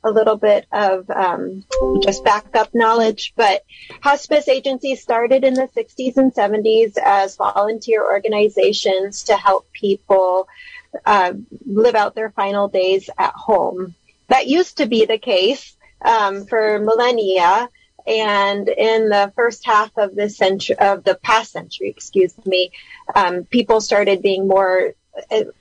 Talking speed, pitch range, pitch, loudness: 140 wpm, 200-245 Hz, 215 Hz, -17 LUFS